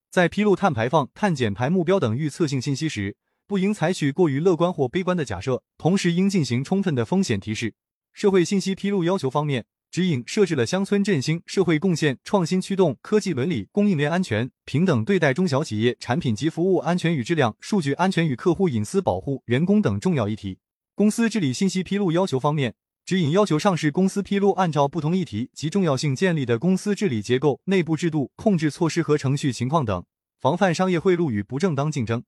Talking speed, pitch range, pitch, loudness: 340 characters per minute, 135-190 Hz, 170 Hz, -22 LUFS